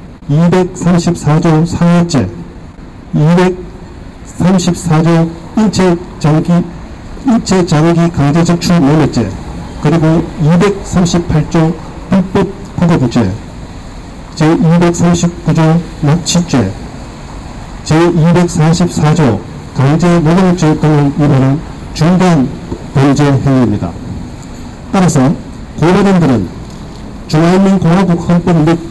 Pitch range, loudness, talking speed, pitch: 145-175 Hz, -10 LUFS, 155 characters per minute, 165 Hz